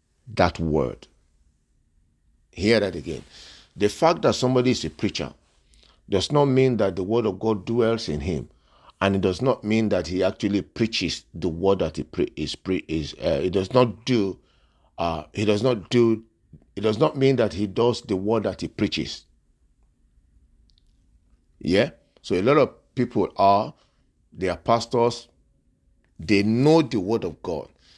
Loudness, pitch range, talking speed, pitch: -23 LUFS, 80-115 Hz, 165 wpm, 95 Hz